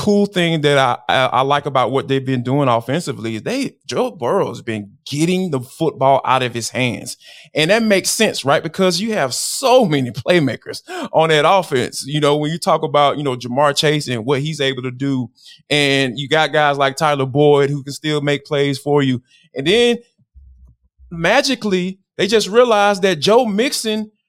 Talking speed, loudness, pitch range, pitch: 195 wpm, -16 LUFS, 135-185 Hz, 145 Hz